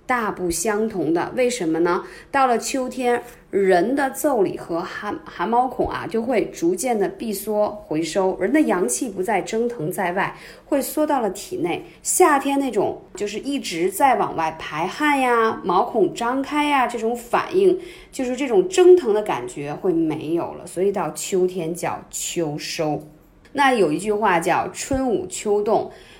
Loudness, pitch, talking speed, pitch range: -21 LUFS, 250 Hz, 235 characters per minute, 195-305 Hz